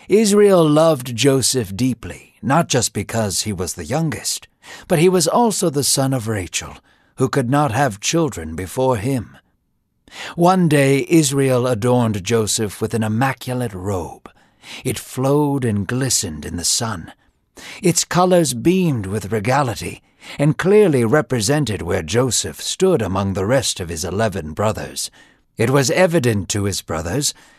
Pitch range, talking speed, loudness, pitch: 100-145 Hz, 145 wpm, -18 LUFS, 125 Hz